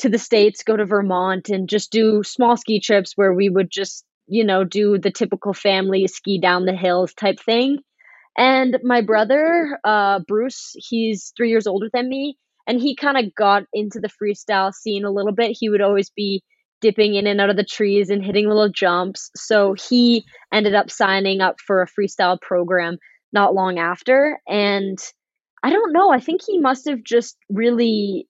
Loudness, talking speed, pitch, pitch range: -18 LUFS, 190 wpm, 210 Hz, 195-235 Hz